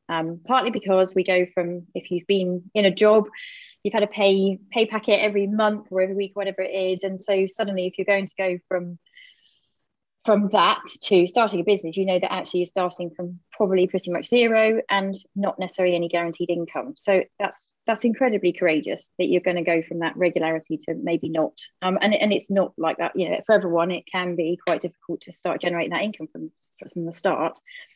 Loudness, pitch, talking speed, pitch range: -23 LUFS, 190 Hz, 215 wpm, 175-205 Hz